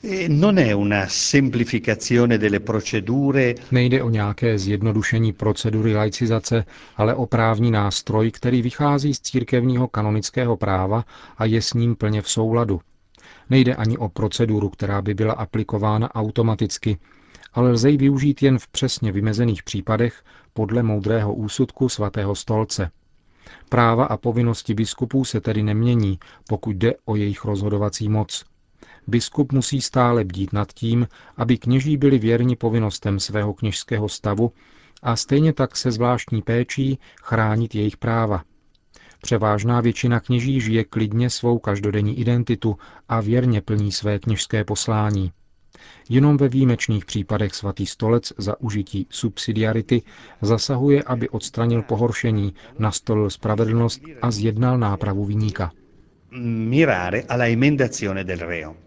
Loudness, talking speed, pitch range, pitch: -21 LUFS, 115 wpm, 105-120 Hz, 115 Hz